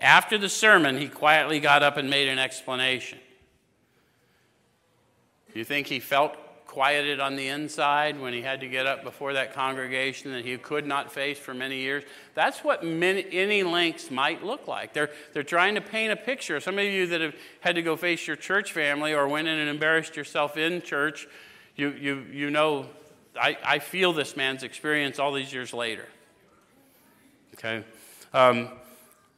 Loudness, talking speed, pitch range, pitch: -25 LUFS, 180 wpm, 135-160 Hz, 145 Hz